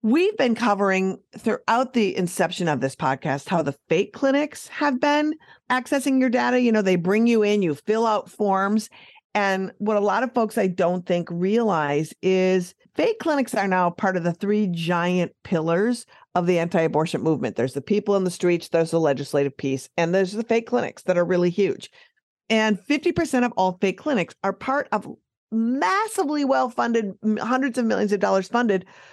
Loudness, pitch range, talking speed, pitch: -22 LUFS, 175-240 Hz, 185 wpm, 200 Hz